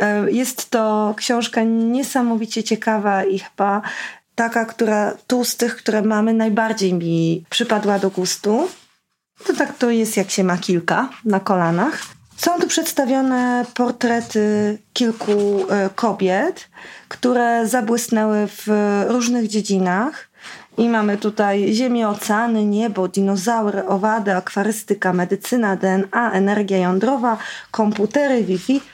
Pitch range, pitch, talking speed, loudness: 200-235 Hz, 215 Hz, 115 wpm, -19 LUFS